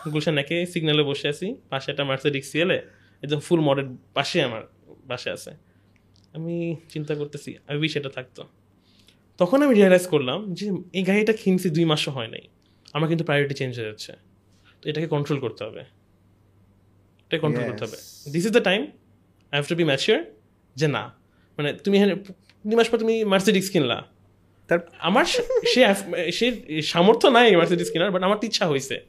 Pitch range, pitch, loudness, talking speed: 115-185 Hz, 155 Hz, -22 LUFS, 165 wpm